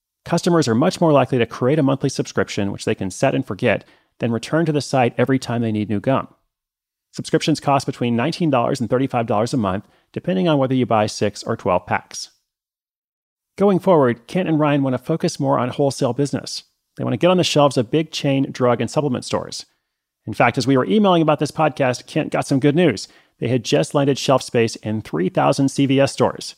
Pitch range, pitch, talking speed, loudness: 120-155 Hz, 135 Hz, 210 wpm, -19 LUFS